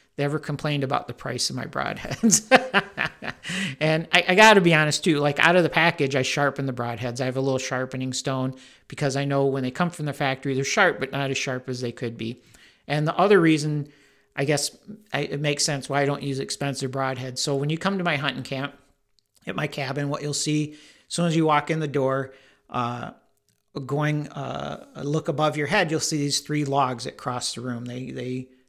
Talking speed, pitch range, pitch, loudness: 225 wpm, 135-155 Hz, 140 Hz, -24 LUFS